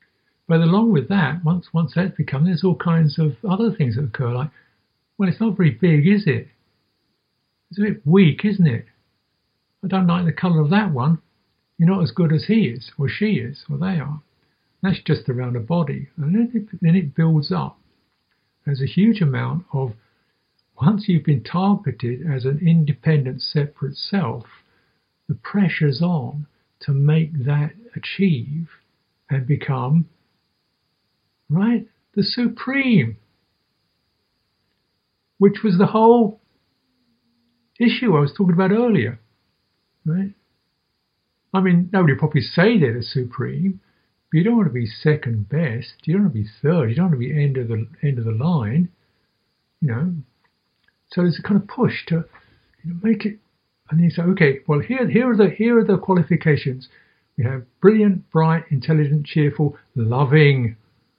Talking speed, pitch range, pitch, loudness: 165 wpm, 135-190 Hz, 160 Hz, -19 LUFS